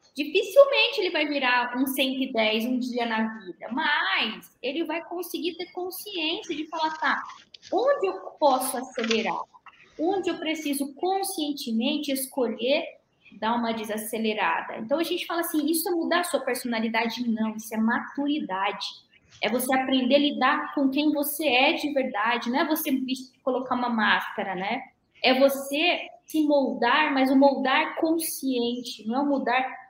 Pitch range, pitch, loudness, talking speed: 245-315 Hz, 275 Hz, -25 LUFS, 155 wpm